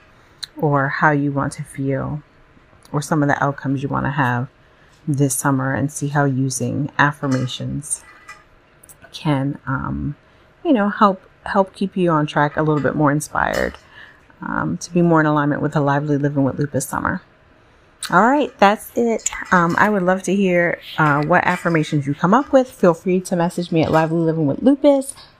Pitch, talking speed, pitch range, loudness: 150 Hz, 180 wpm, 140-180 Hz, -18 LUFS